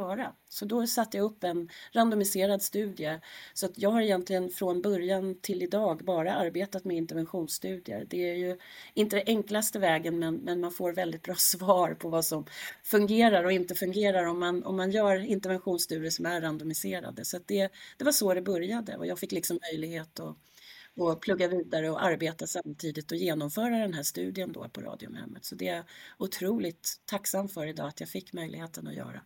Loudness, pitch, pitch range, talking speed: -30 LUFS, 180 Hz, 165-200 Hz, 185 wpm